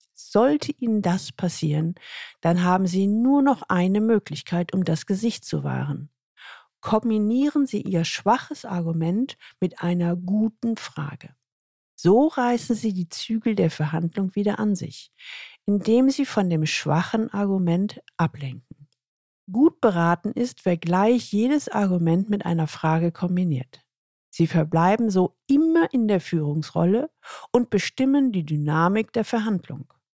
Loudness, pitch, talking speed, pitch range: -23 LUFS, 195 Hz, 130 wpm, 165-230 Hz